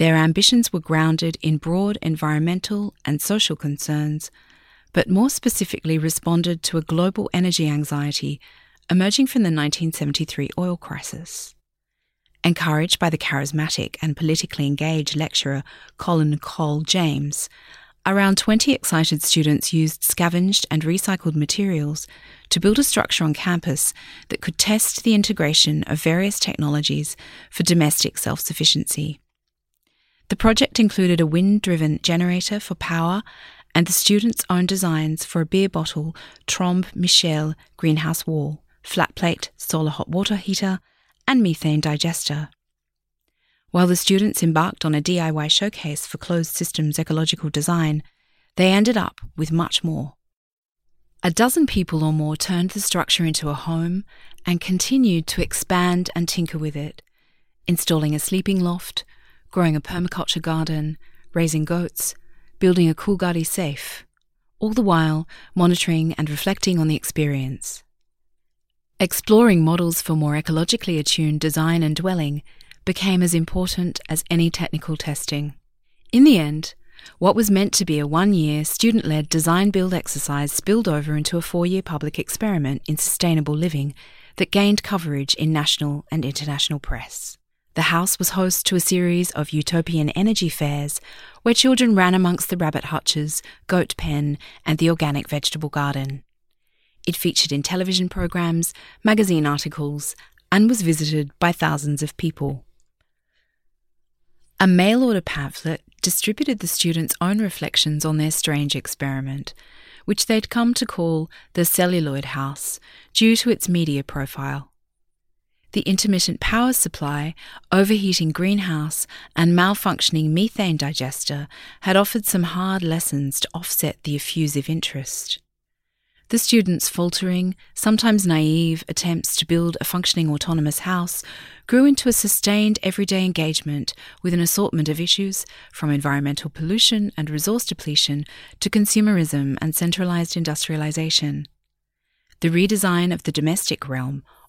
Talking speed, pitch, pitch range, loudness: 135 wpm, 165 Hz, 150-185 Hz, -20 LUFS